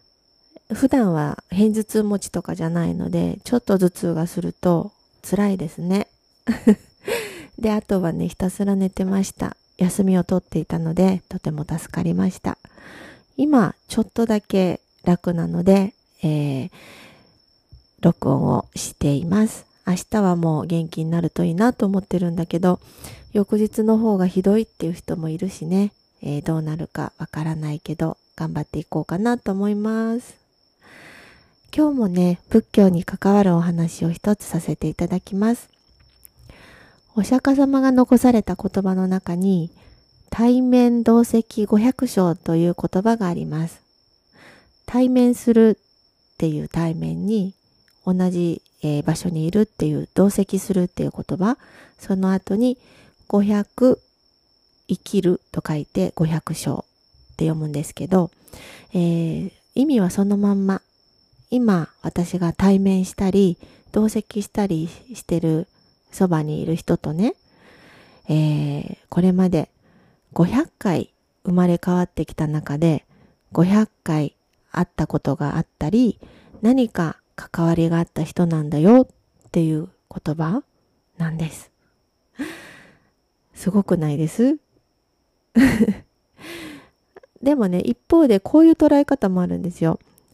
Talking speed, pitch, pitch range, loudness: 250 characters per minute, 185 Hz, 165-215 Hz, -20 LUFS